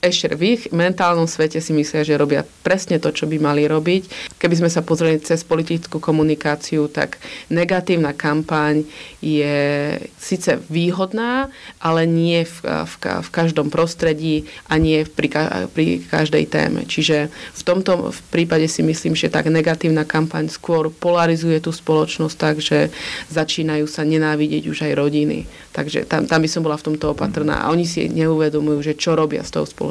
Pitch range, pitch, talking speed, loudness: 150-165 Hz, 160 Hz, 170 wpm, -19 LUFS